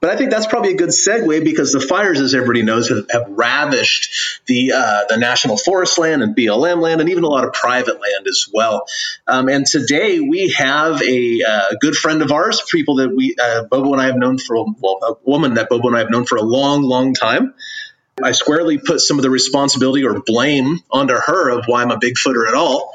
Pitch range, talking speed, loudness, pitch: 125-210 Hz, 235 wpm, -14 LUFS, 140 Hz